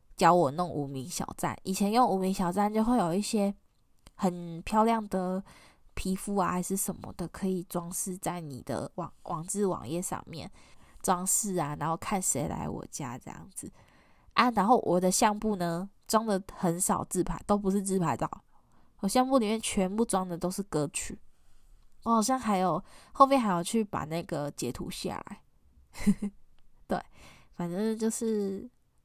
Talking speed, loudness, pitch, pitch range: 235 characters per minute, -30 LUFS, 190 Hz, 175-210 Hz